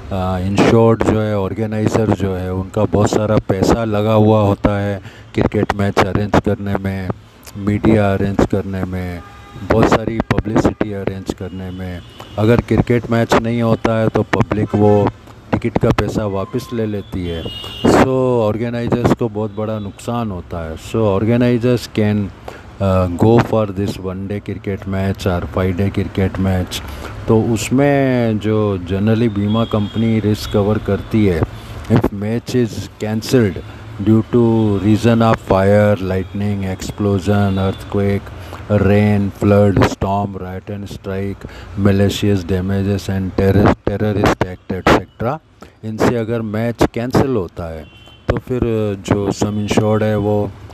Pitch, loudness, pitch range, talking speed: 105 Hz, -16 LUFS, 100-110 Hz, 135 wpm